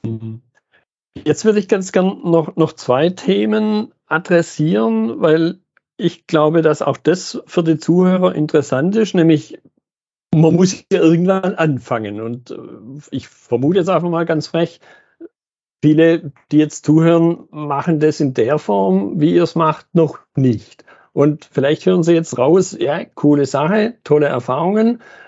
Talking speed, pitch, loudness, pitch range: 145 wpm, 160 Hz, -16 LUFS, 145-180 Hz